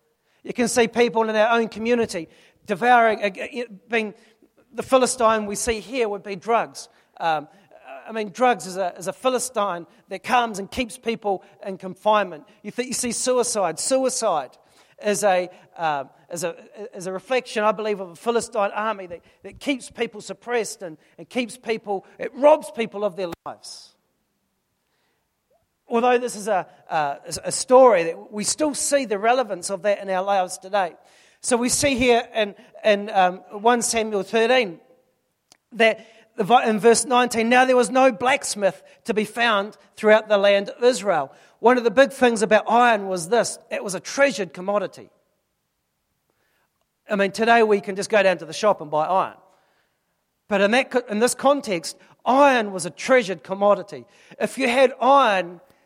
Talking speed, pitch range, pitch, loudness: 165 wpm, 195-245 Hz, 220 Hz, -21 LUFS